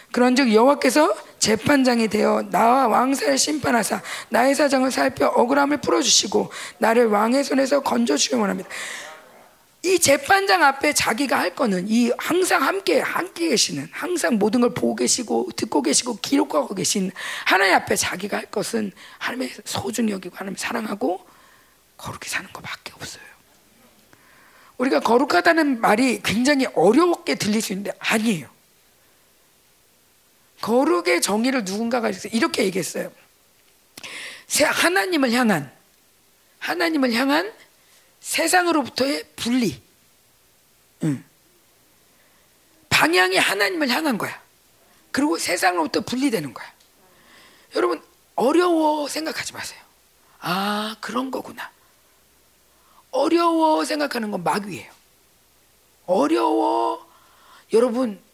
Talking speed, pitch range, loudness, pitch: 275 characters per minute, 220-310 Hz, -20 LUFS, 265 Hz